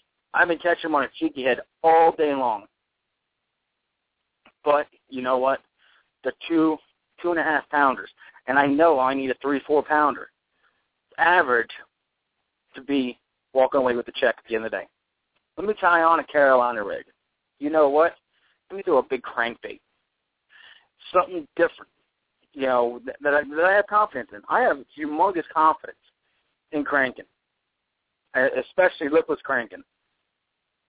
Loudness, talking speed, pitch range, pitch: -22 LUFS, 155 wpm, 135-170 Hz, 150 Hz